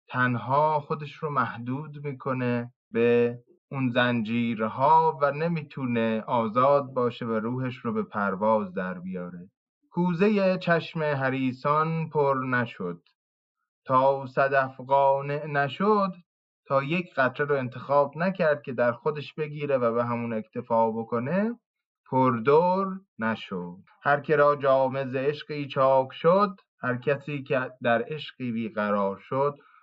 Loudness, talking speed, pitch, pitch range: -26 LUFS, 120 wpm, 135 Hz, 120-150 Hz